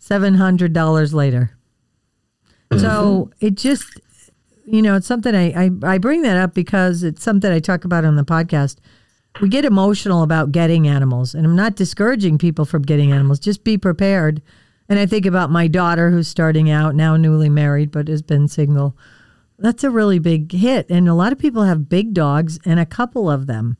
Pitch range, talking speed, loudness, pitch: 150-195 Hz, 190 wpm, -16 LUFS, 170 Hz